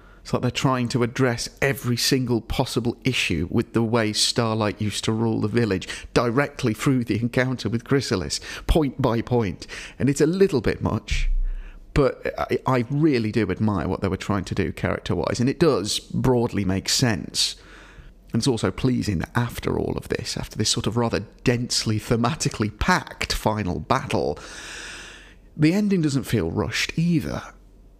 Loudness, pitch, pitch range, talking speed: -23 LUFS, 115 Hz, 105-130 Hz, 165 wpm